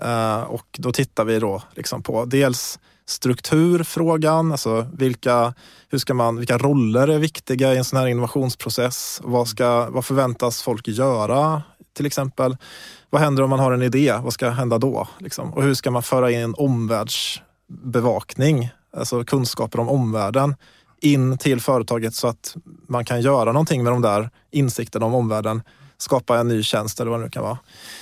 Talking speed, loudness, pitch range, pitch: 170 wpm, -21 LUFS, 115-140 Hz, 125 Hz